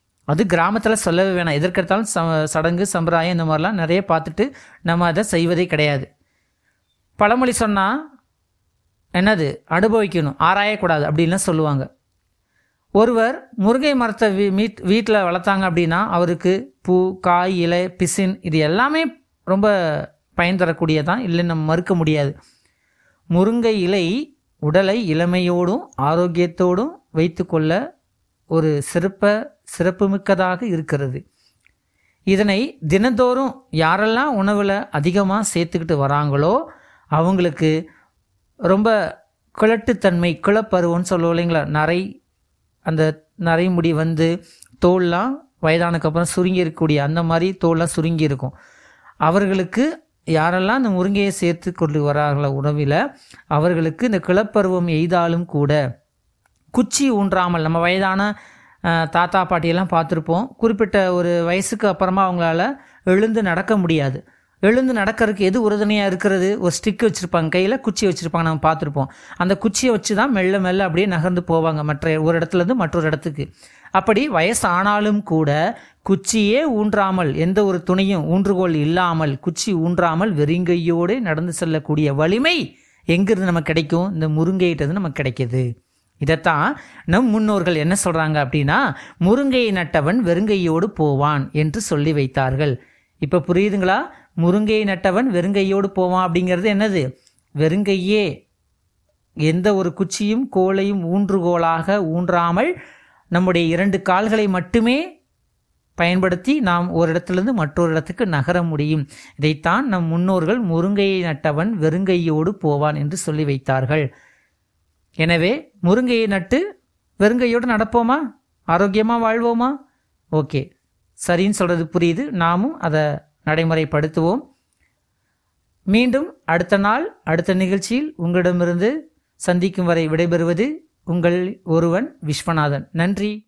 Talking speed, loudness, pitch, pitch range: 105 wpm, -18 LUFS, 175 Hz, 160-205 Hz